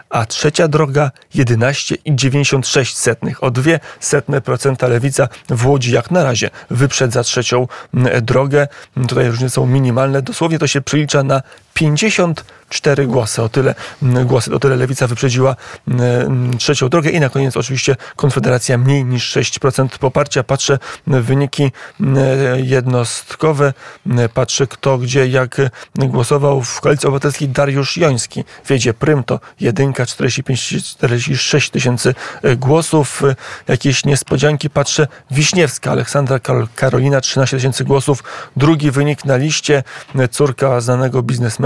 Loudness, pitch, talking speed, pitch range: -14 LUFS, 135 Hz, 120 wpm, 125-145 Hz